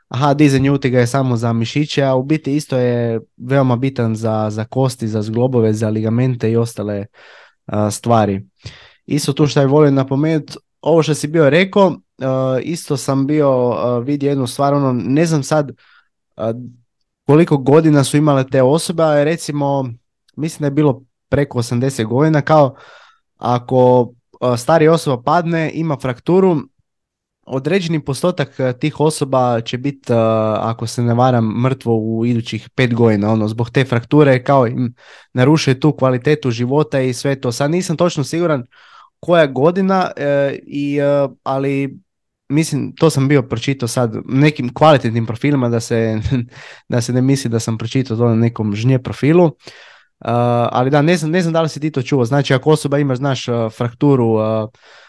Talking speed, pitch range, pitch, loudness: 160 wpm, 120-150 Hz, 130 Hz, -16 LUFS